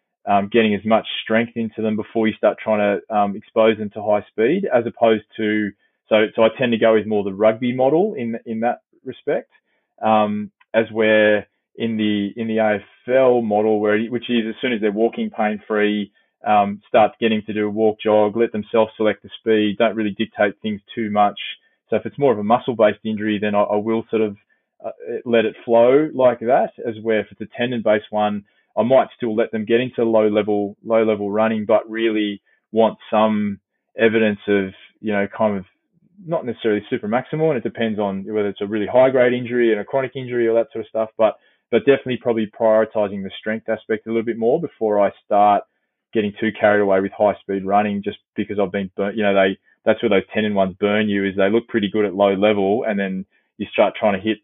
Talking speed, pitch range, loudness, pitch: 220 wpm, 105-115 Hz, -19 LUFS, 110 Hz